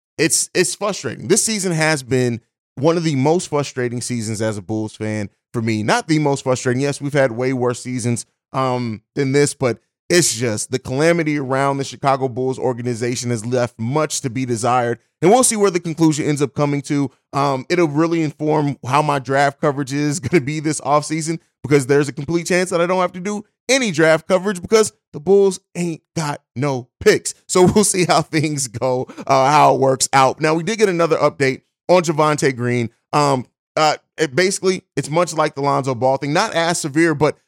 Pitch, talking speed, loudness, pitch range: 145 Hz, 205 wpm, -18 LUFS, 130-165 Hz